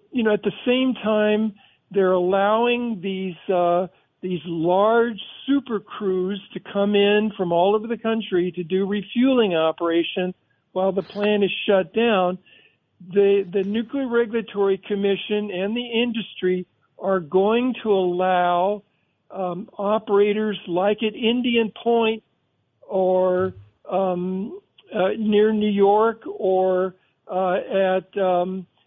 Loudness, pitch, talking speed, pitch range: -22 LUFS, 200 Hz, 125 wpm, 185-215 Hz